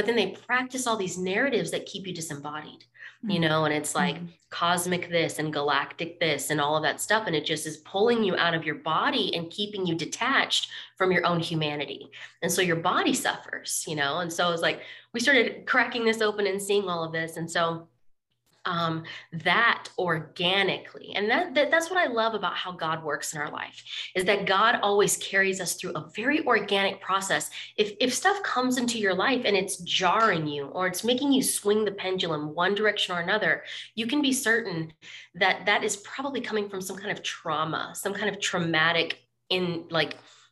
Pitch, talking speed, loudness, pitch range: 180 Hz, 205 wpm, -26 LUFS, 165-210 Hz